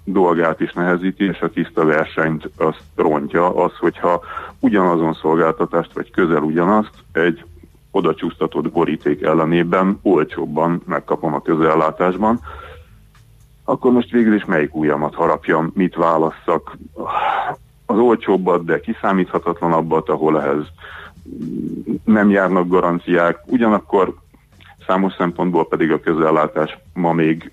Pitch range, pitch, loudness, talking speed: 80-95 Hz, 85 Hz, -17 LUFS, 105 wpm